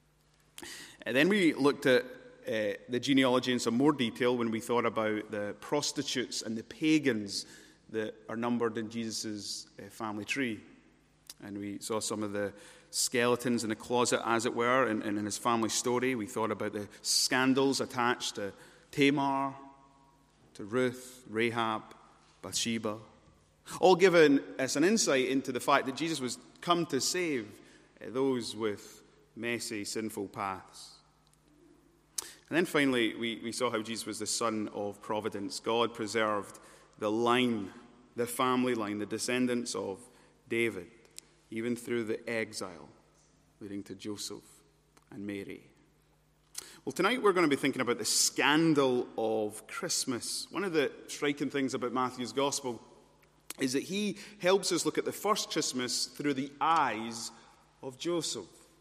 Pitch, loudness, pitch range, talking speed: 120 Hz, -31 LUFS, 110-135 Hz, 150 wpm